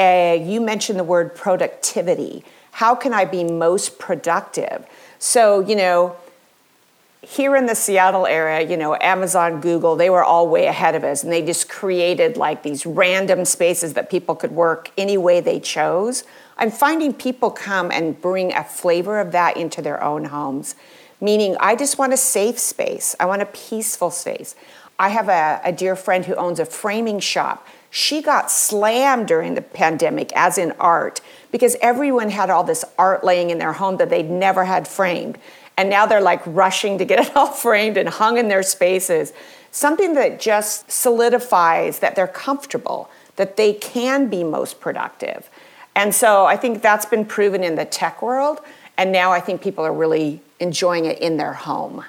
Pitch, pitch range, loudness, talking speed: 190 Hz, 175-230 Hz, -18 LUFS, 180 wpm